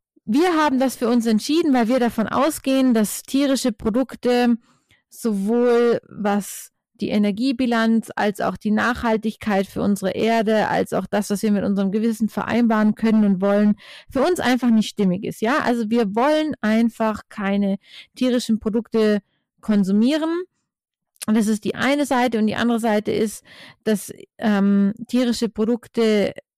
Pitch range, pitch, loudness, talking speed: 210-245 Hz, 225 Hz, -20 LUFS, 150 wpm